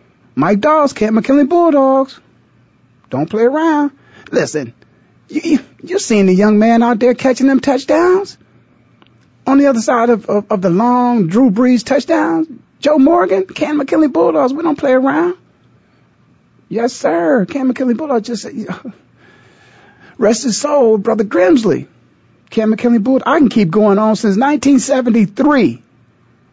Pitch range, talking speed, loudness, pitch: 225-290 Hz, 145 wpm, -13 LUFS, 255 Hz